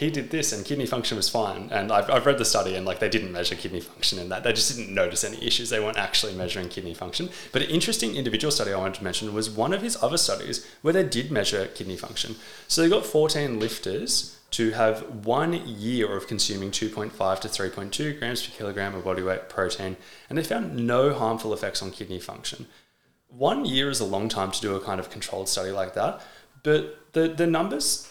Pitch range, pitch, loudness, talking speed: 105-145 Hz, 115 Hz, -26 LUFS, 225 wpm